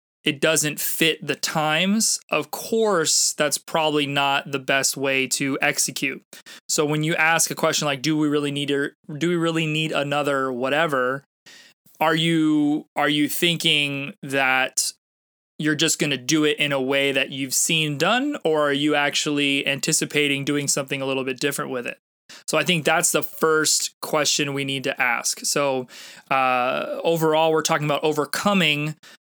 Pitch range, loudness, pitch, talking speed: 140-160 Hz, -21 LUFS, 150 Hz, 170 wpm